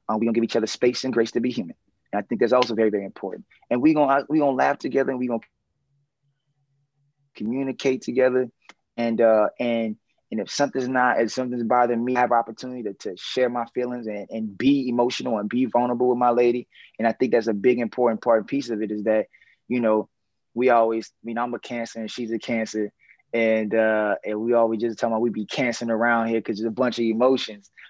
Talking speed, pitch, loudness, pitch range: 230 wpm, 120 Hz, -23 LUFS, 115-125 Hz